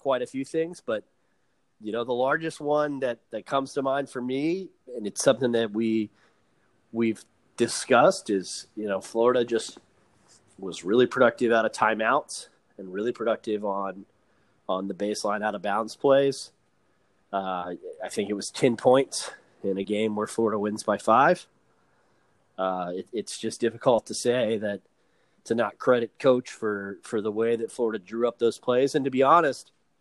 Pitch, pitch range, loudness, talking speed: 115 Hz, 105-135 Hz, -26 LUFS, 175 wpm